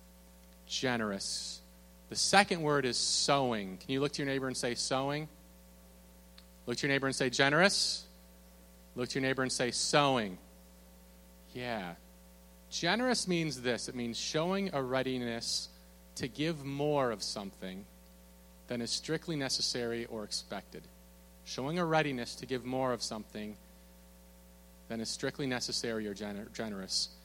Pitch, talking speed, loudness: 115 Hz, 140 wpm, -33 LUFS